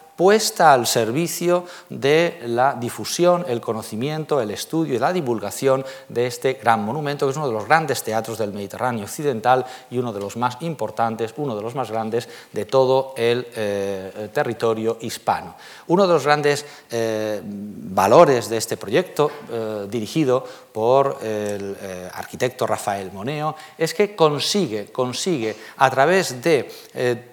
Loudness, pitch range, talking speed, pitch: -21 LUFS, 110-150 Hz, 150 wpm, 125 Hz